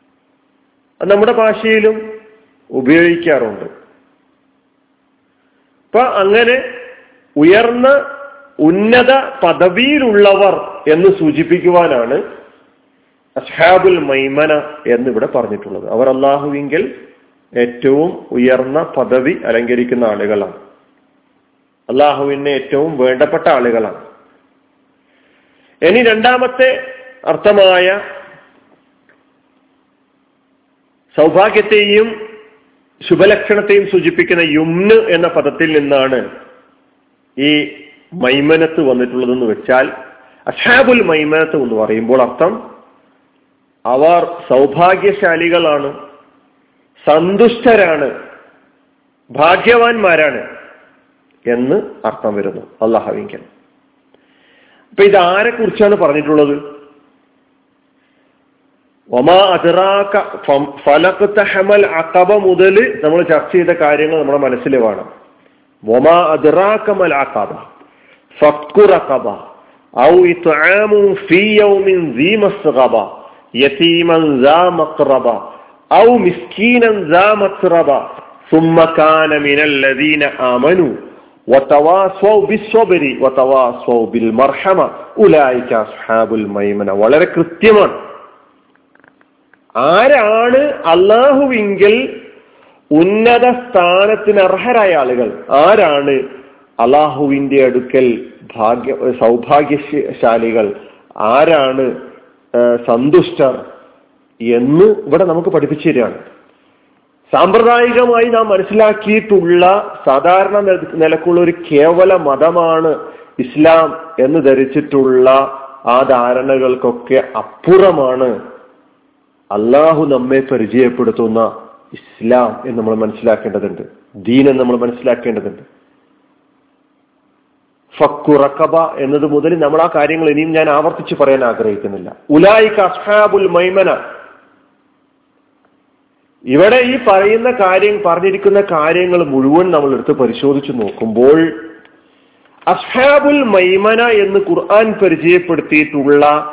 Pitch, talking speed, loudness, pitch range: 180 Hz, 70 wpm, -11 LUFS, 145-235 Hz